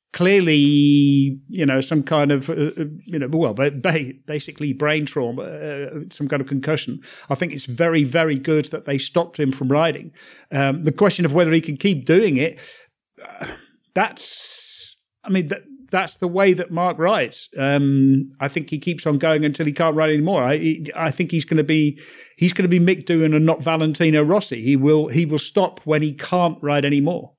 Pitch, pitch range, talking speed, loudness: 155 Hz, 145-170 Hz, 195 wpm, -19 LUFS